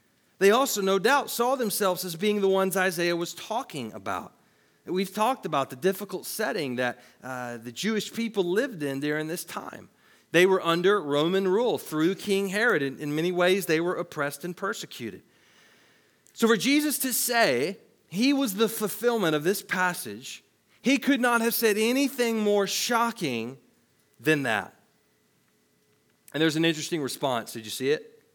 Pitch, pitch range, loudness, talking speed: 190 Hz, 165-225 Hz, -26 LUFS, 165 wpm